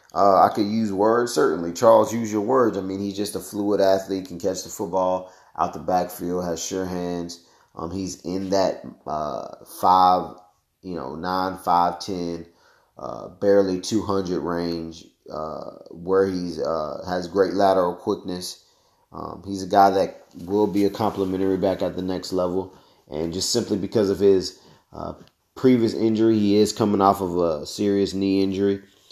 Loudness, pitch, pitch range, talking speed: -22 LUFS, 95 Hz, 90-100 Hz, 170 wpm